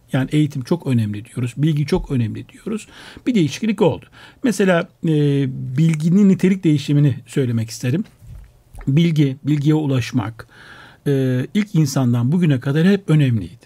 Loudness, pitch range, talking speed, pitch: -18 LUFS, 125-165 Hz, 125 wpm, 145 Hz